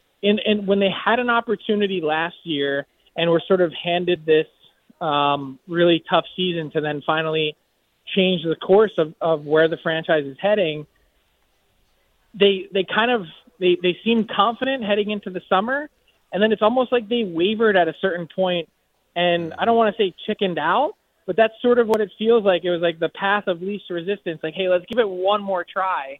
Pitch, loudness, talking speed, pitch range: 185 Hz, -21 LUFS, 200 wpm, 165-210 Hz